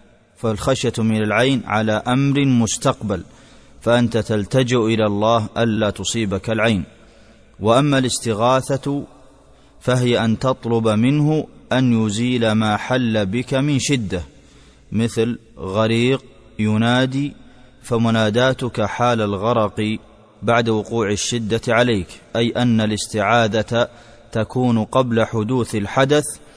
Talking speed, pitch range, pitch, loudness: 95 wpm, 110-125 Hz, 115 Hz, -19 LUFS